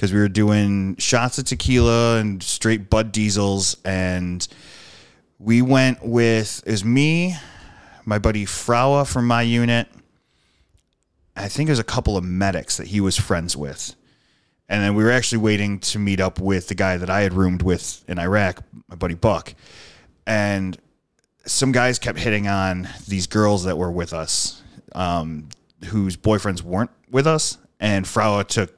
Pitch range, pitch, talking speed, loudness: 90-115 Hz, 100 Hz, 165 wpm, -20 LUFS